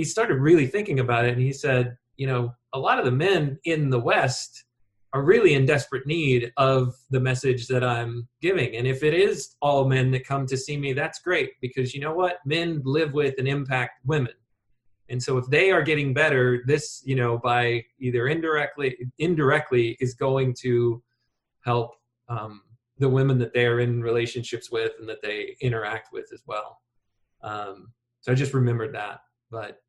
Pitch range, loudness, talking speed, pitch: 120-145 Hz, -24 LUFS, 190 wpm, 130 Hz